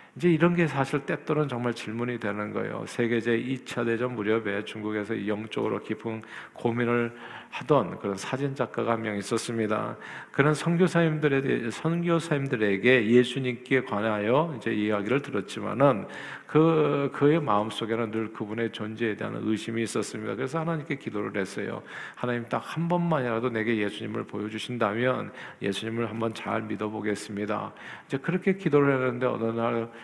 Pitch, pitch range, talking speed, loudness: 115 Hz, 110-135 Hz, 360 characters per minute, -27 LUFS